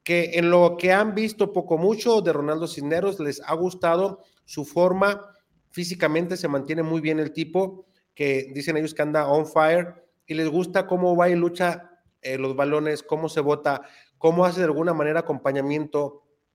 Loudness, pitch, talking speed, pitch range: -23 LUFS, 165 Hz, 180 wpm, 150-180 Hz